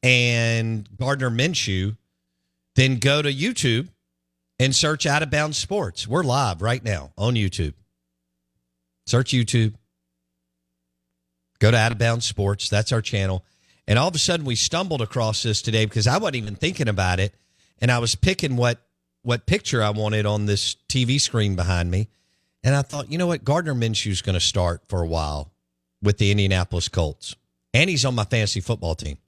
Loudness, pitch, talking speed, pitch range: -22 LUFS, 105 Hz, 170 wpm, 85-125 Hz